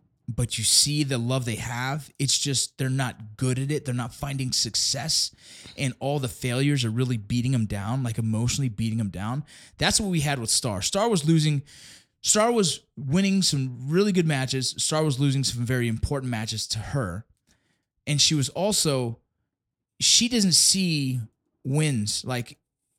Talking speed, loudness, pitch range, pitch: 170 wpm, -24 LUFS, 120-145 Hz, 130 Hz